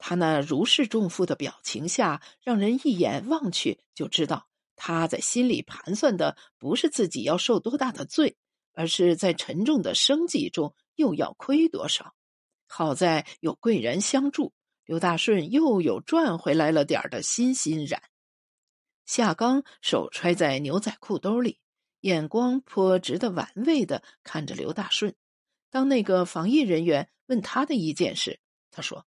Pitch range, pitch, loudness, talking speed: 175-270 Hz, 220 Hz, -25 LUFS, 225 characters per minute